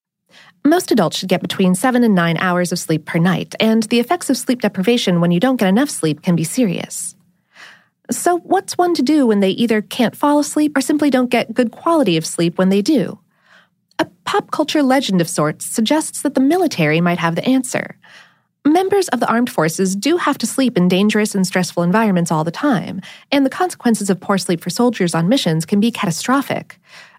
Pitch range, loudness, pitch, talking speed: 180-275 Hz, -16 LUFS, 220 Hz, 205 wpm